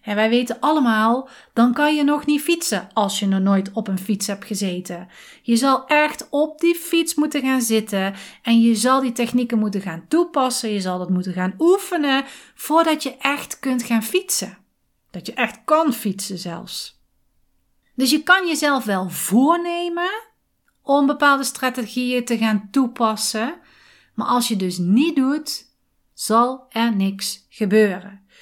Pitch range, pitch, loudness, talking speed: 210-295 Hz, 245 Hz, -20 LUFS, 160 wpm